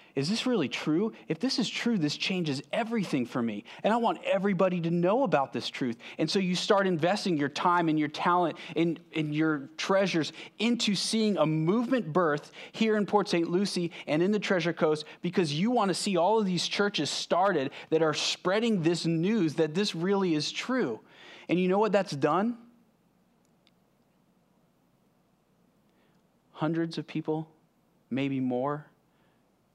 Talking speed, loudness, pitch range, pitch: 165 wpm, -28 LUFS, 155-205 Hz, 175 Hz